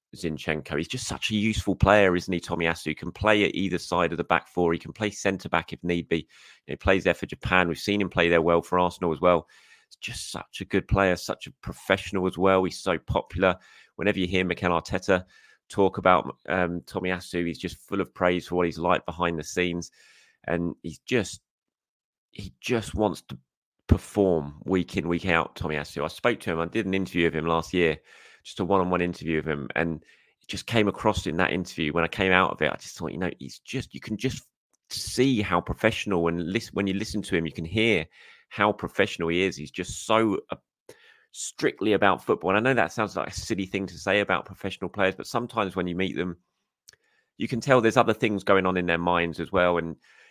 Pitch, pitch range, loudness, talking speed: 90 Hz, 85-100 Hz, -26 LUFS, 225 wpm